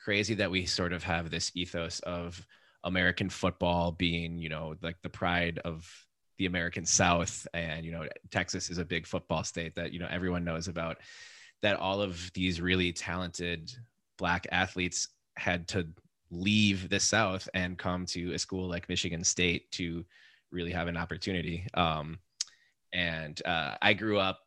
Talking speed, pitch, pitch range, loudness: 165 wpm, 90 Hz, 85-95 Hz, -32 LUFS